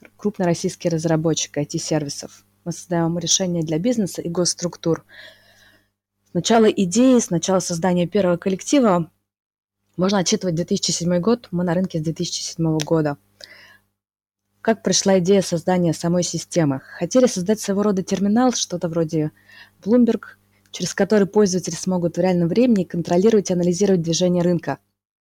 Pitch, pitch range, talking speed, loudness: 175 Hz, 160-195 Hz, 125 wpm, -20 LUFS